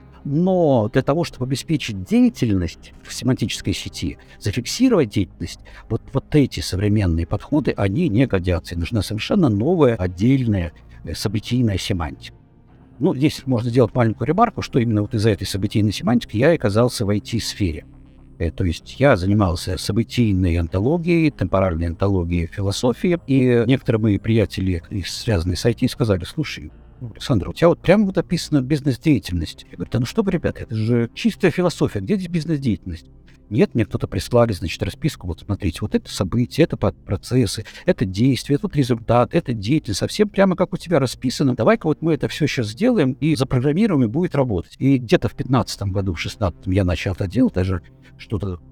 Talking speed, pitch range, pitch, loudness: 165 wpm, 95-140 Hz, 115 Hz, -20 LUFS